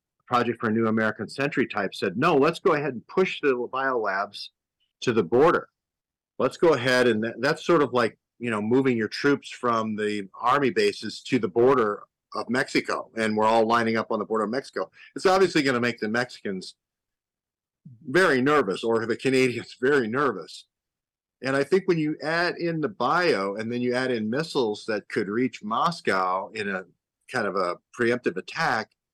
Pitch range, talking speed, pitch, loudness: 115-145 Hz, 190 wpm, 120 Hz, -25 LUFS